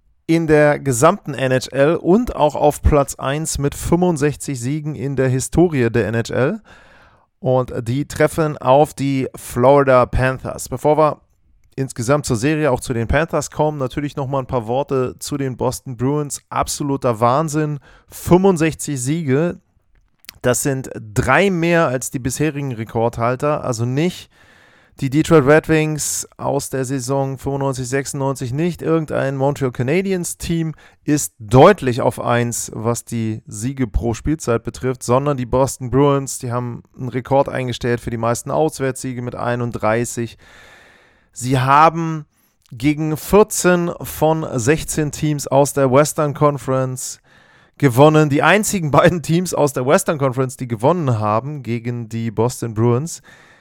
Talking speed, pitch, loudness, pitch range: 135 wpm, 135 Hz, -18 LUFS, 125-150 Hz